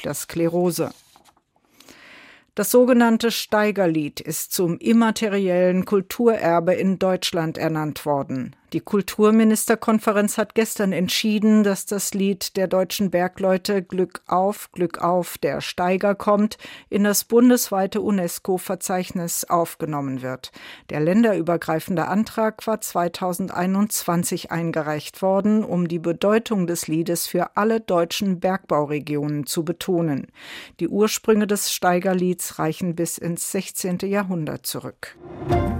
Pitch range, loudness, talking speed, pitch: 170-210 Hz, -21 LUFS, 105 wpm, 185 Hz